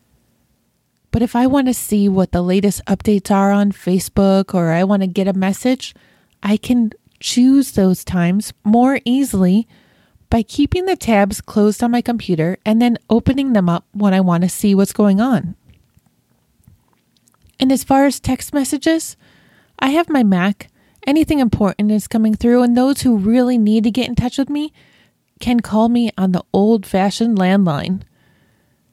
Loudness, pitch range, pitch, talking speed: -16 LUFS, 195-250 Hz, 215 Hz, 170 wpm